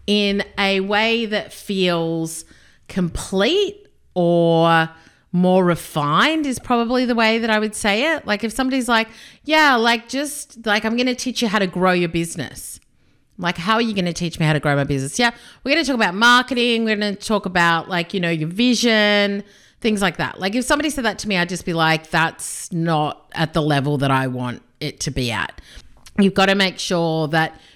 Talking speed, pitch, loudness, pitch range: 200 wpm, 195 Hz, -19 LUFS, 165-230 Hz